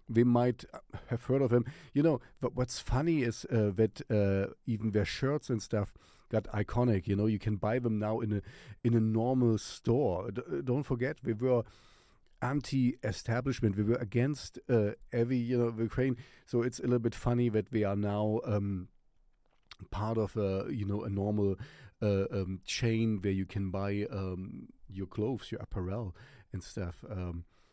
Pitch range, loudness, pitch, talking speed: 100-125 Hz, -33 LUFS, 110 Hz, 175 wpm